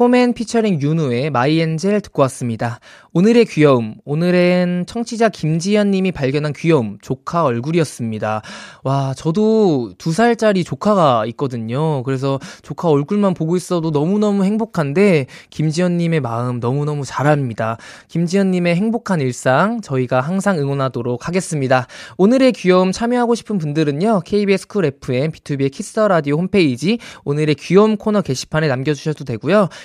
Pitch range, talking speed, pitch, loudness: 135-200 Hz, 365 characters per minute, 160 Hz, -17 LUFS